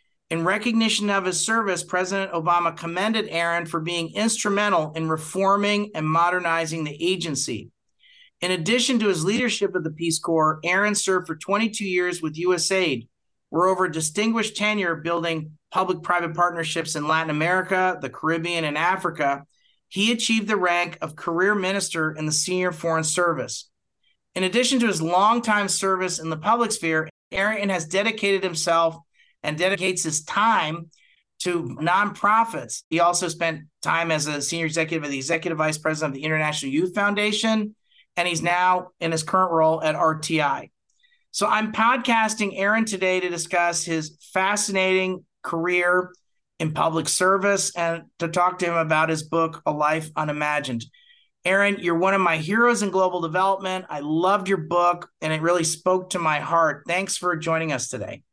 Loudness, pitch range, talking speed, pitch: -22 LUFS, 165-195 Hz, 160 wpm, 175 Hz